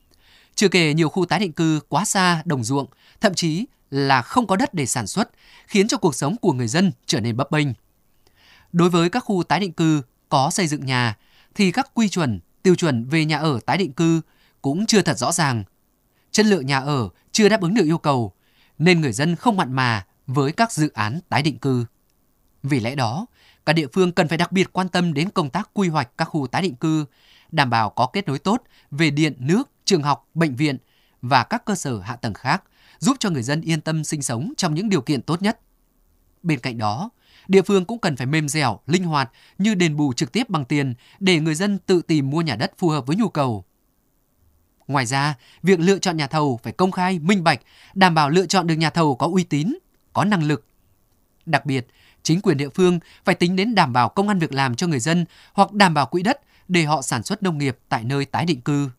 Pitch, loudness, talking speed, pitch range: 160 Hz, -21 LUFS, 235 wpm, 135-185 Hz